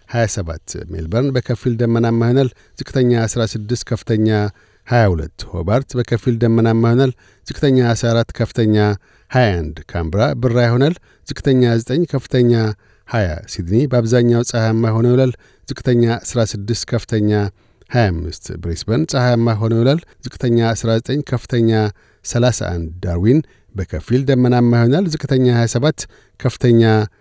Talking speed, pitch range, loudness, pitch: 105 wpm, 105-125 Hz, -17 LUFS, 115 Hz